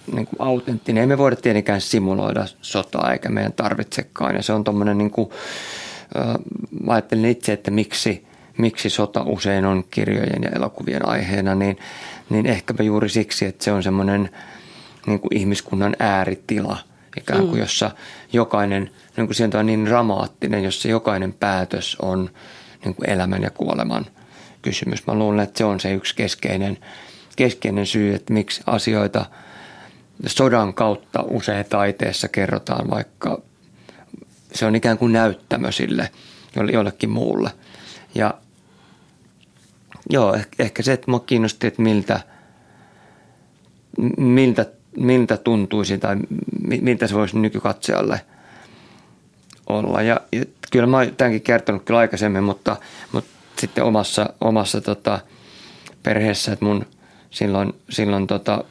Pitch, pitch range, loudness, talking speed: 105 Hz, 100-115 Hz, -20 LUFS, 130 wpm